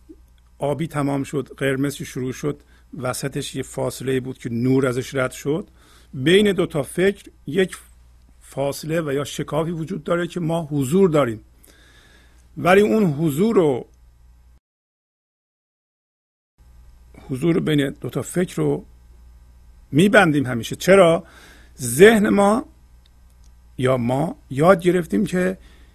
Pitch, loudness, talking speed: 135 Hz, -20 LUFS, 115 wpm